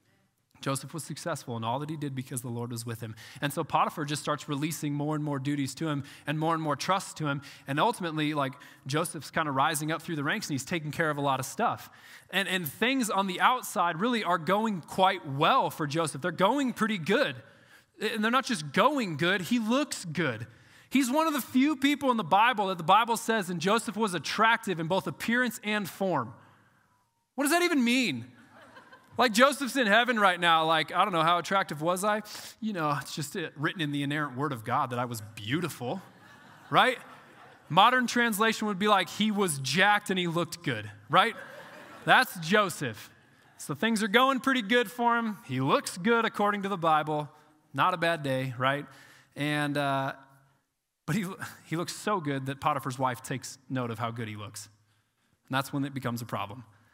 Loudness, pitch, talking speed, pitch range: -28 LUFS, 165 Hz, 210 wpm, 140-210 Hz